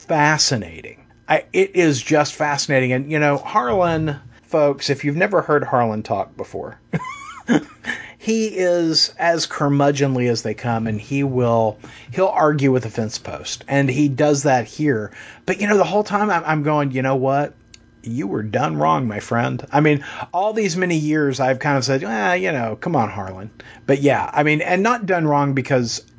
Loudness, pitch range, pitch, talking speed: -19 LUFS, 130-160 Hz, 145 Hz, 190 wpm